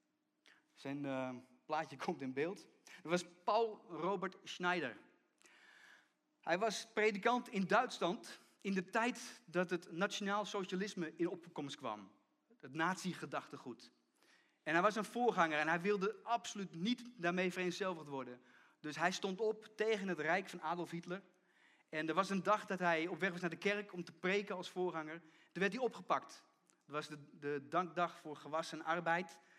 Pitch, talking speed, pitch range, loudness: 180 Hz, 165 wpm, 160-200 Hz, -40 LUFS